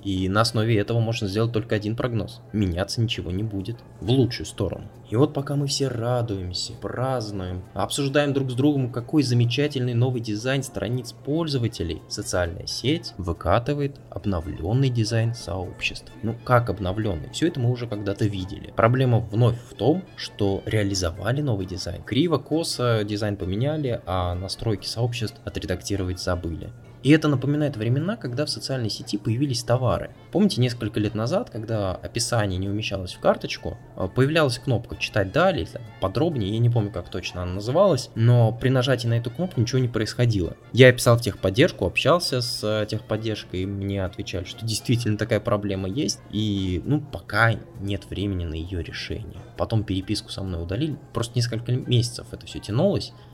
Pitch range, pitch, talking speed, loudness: 100-125 Hz, 115 Hz, 160 wpm, -24 LUFS